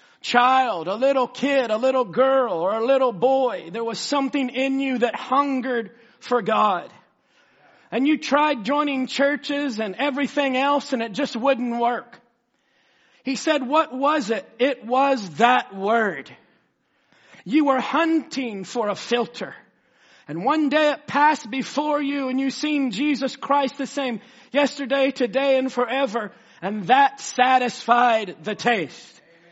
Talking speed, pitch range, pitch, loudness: 145 wpm, 235-280 Hz, 260 Hz, -22 LUFS